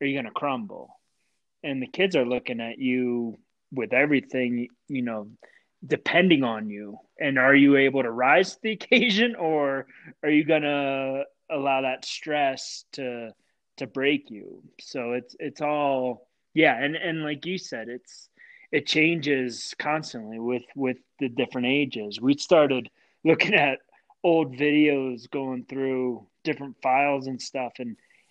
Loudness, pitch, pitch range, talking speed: -25 LUFS, 135 Hz, 125-150 Hz, 150 wpm